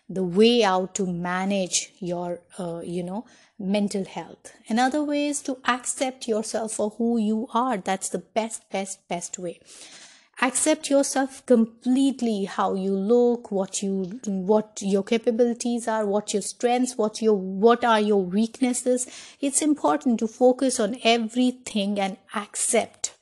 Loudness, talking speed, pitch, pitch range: -24 LUFS, 145 wpm, 220 Hz, 195-245 Hz